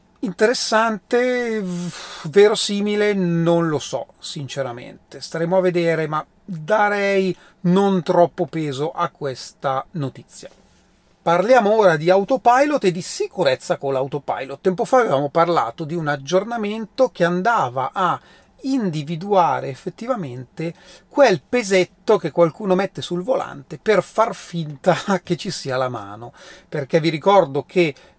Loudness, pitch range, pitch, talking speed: -20 LUFS, 160-205 Hz, 180 Hz, 120 wpm